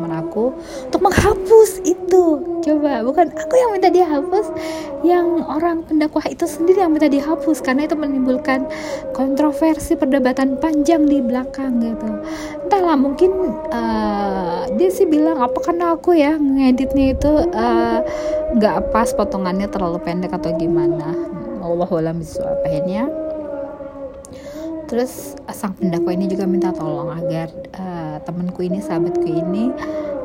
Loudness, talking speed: -18 LUFS, 125 wpm